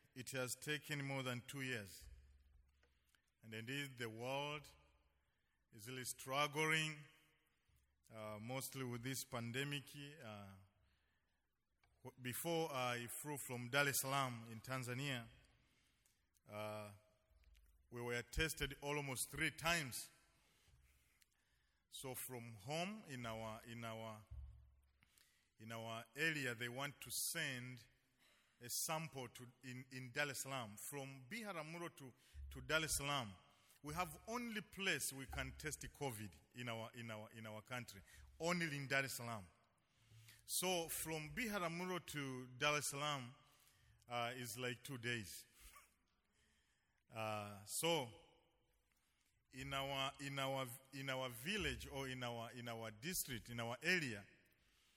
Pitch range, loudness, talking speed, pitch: 110-145 Hz, -45 LUFS, 125 wpm, 125 Hz